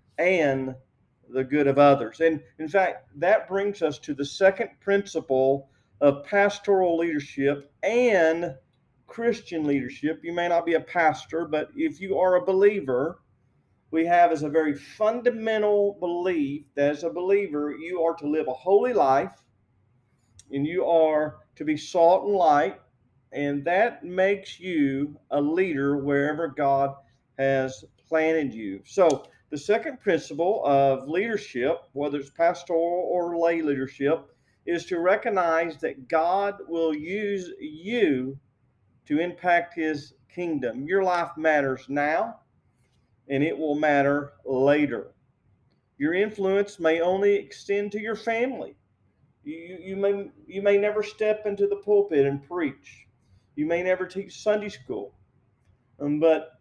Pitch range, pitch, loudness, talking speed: 140-190 Hz, 160 Hz, -25 LUFS, 140 wpm